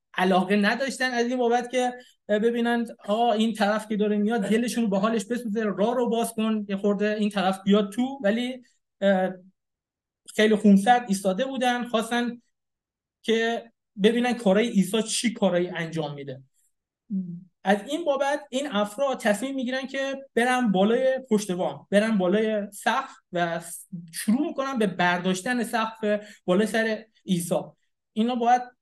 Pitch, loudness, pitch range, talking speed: 220 Hz, -25 LUFS, 195-245 Hz, 140 wpm